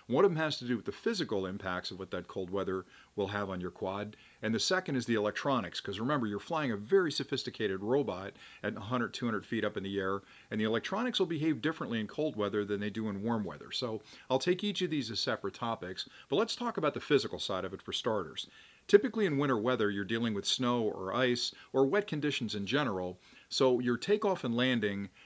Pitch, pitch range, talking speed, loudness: 120 Hz, 105-155 Hz, 230 wpm, -33 LUFS